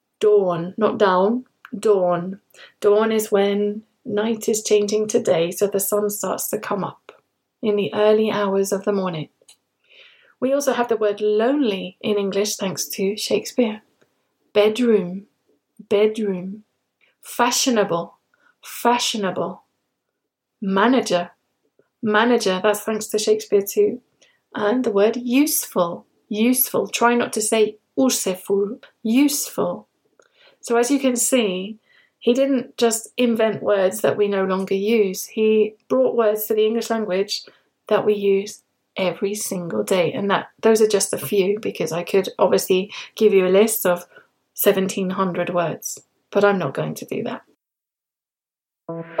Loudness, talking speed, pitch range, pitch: -20 LUFS, 135 wpm, 195-230 Hz, 210 Hz